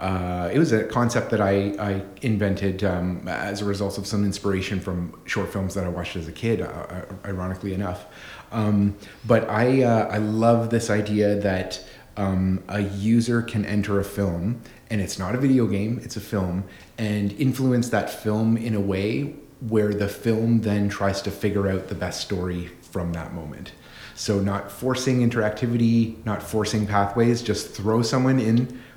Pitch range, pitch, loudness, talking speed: 95-115 Hz, 105 Hz, -24 LUFS, 175 wpm